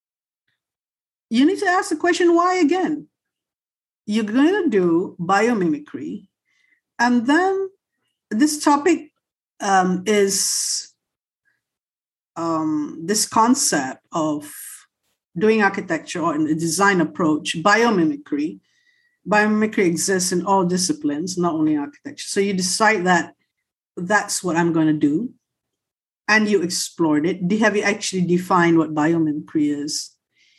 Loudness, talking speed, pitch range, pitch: -19 LUFS, 120 wpm, 170-290 Hz, 205 Hz